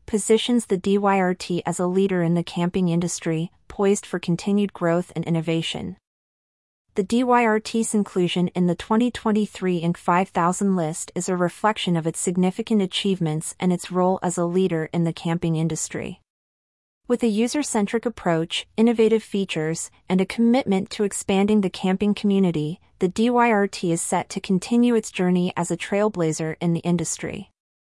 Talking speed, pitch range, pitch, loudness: 150 wpm, 170-210 Hz, 185 Hz, -22 LUFS